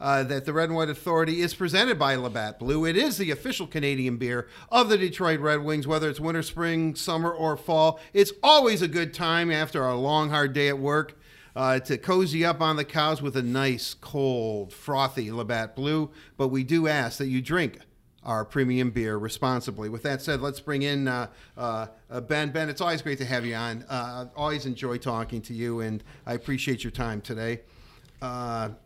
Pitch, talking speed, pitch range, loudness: 140 Hz, 205 wpm, 125-160 Hz, -26 LUFS